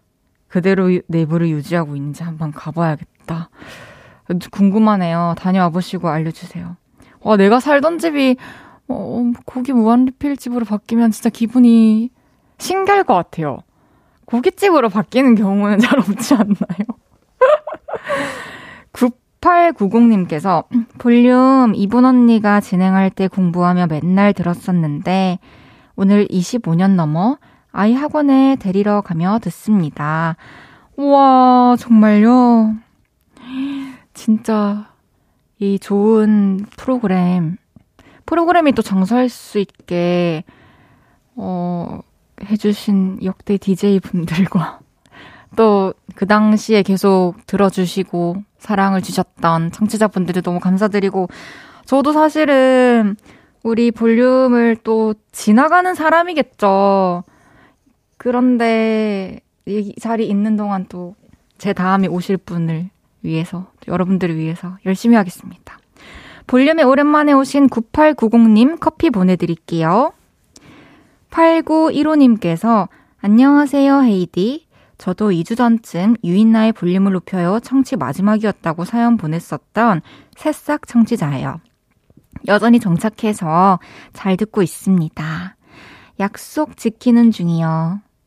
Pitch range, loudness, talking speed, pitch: 180-245 Hz, -15 LUFS, 235 characters per minute, 210 Hz